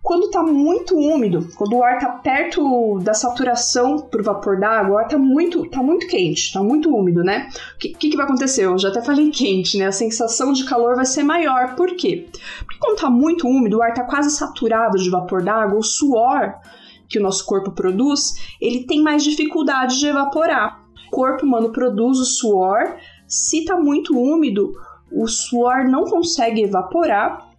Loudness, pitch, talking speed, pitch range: -17 LUFS, 260 Hz, 190 wpm, 225-310 Hz